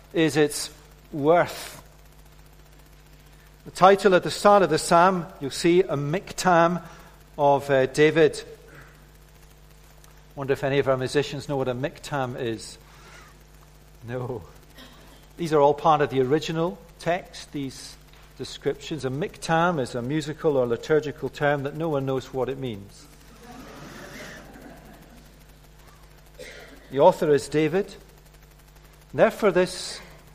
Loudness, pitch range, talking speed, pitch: -23 LUFS, 135-170 Hz, 125 wpm, 150 Hz